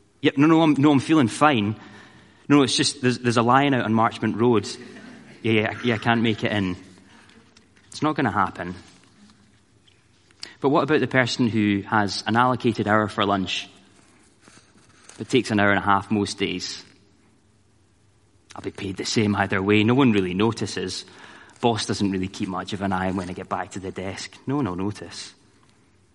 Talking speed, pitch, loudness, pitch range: 195 wpm, 105 Hz, -22 LUFS, 100-120 Hz